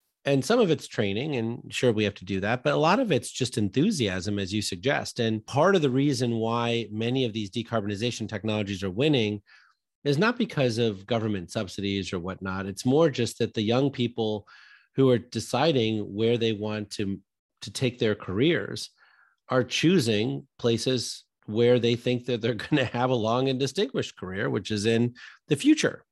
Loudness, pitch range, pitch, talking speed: -26 LUFS, 105-130 Hz, 115 Hz, 190 wpm